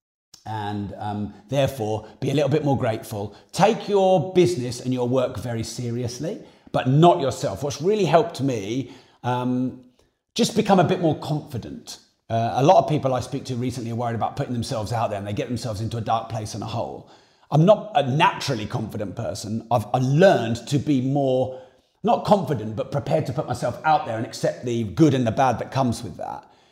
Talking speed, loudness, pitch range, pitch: 200 wpm, -23 LUFS, 115-150 Hz, 125 Hz